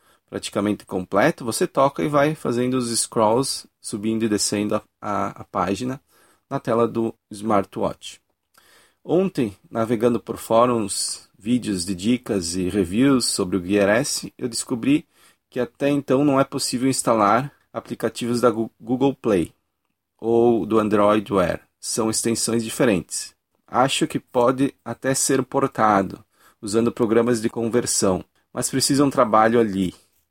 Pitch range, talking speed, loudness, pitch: 105-130 Hz, 135 wpm, -21 LUFS, 115 Hz